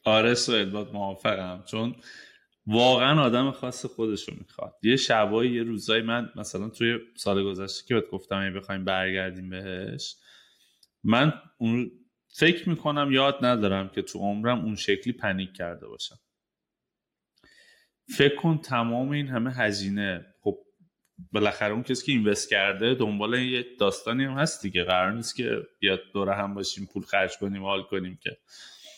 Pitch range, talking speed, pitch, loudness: 100-125 Hz, 150 wpm, 110 Hz, -26 LUFS